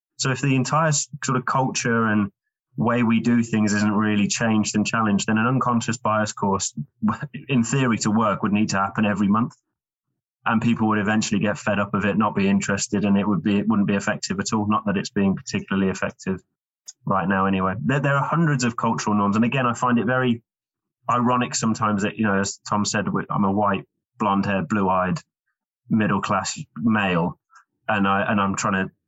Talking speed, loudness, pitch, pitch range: 200 wpm, -22 LUFS, 110 Hz, 100-125 Hz